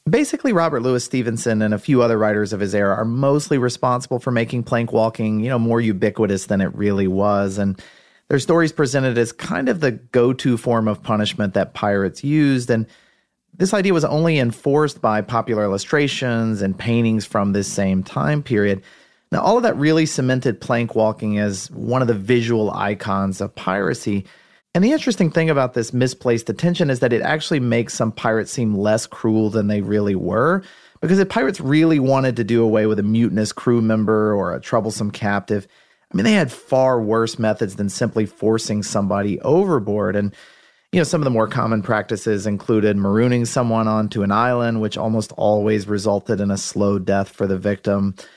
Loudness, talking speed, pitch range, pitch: -19 LUFS, 185 wpm, 105-130 Hz, 115 Hz